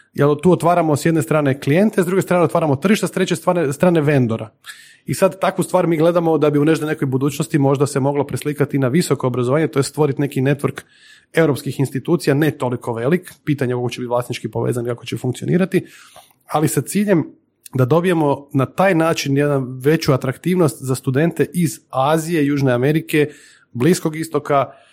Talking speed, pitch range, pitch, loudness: 180 wpm, 135-170 Hz, 150 Hz, -18 LUFS